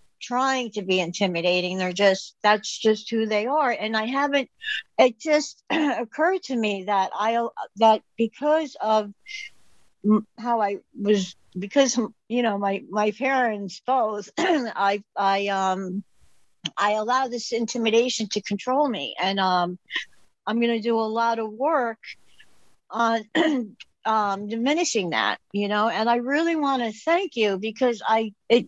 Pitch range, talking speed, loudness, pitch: 205-255 Hz, 140 wpm, -24 LUFS, 225 Hz